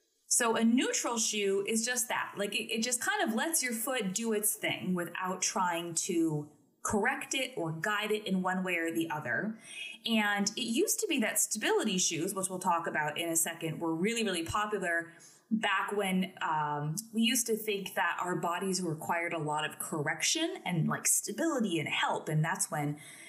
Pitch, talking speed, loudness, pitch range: 195 Hz, 195 wpm, -31 LUFS, 170-225 Hz